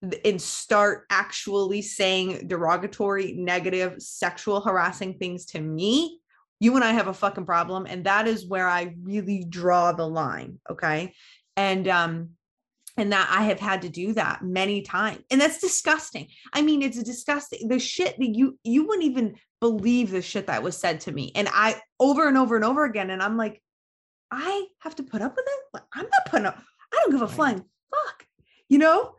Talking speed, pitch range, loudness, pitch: 195 wpm, 185-265 Hz, -24 LUFS, 210 Hz